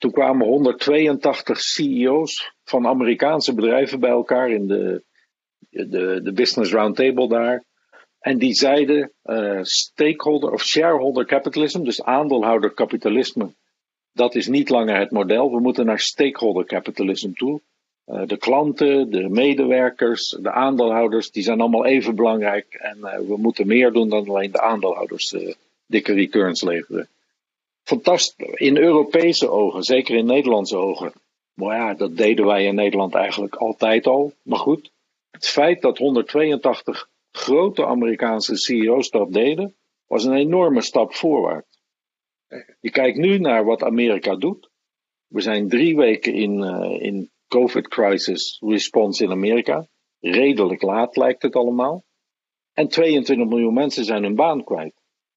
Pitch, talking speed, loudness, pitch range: 125 Hz, 140 wpm, -19 LUFS, 110-140 Hz